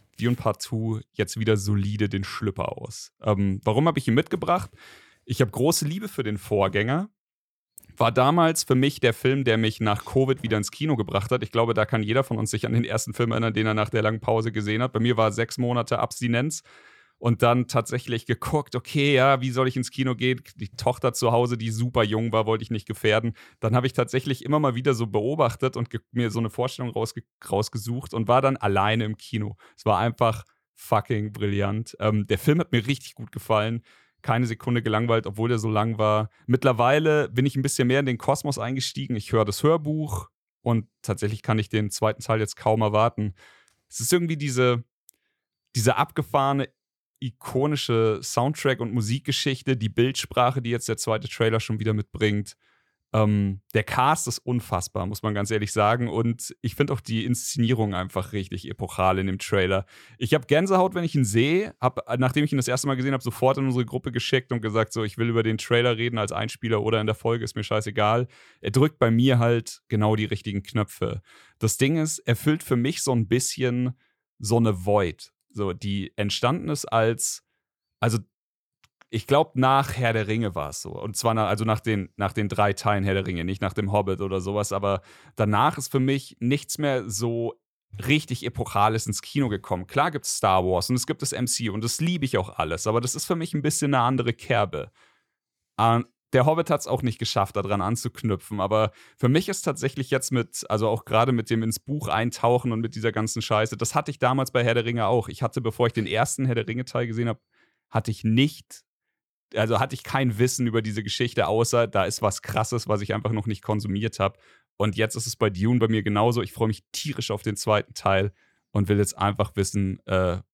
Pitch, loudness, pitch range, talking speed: 115 Hz, -25 LUFS, 110-130 Hz, 215 wpm